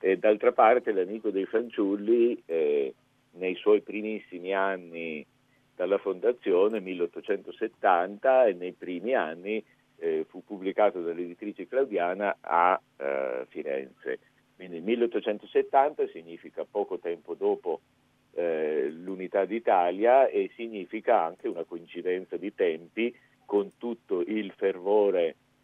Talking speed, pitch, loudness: 110 wpm, 120 Hz, -28 LUFS